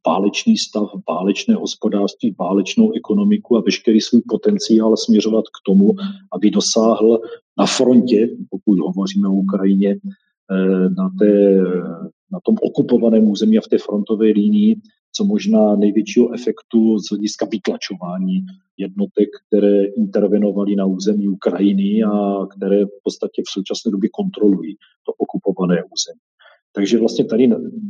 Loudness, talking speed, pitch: -17 LUFS, 125 wpm, 110 Hz